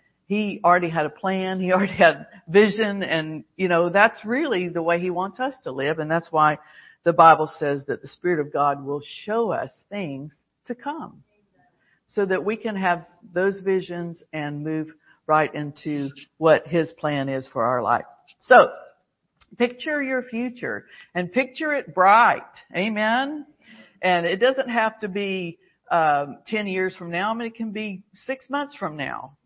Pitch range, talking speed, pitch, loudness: 155-220 Hz, 175 wpm, 185 Hz, -22 LUFS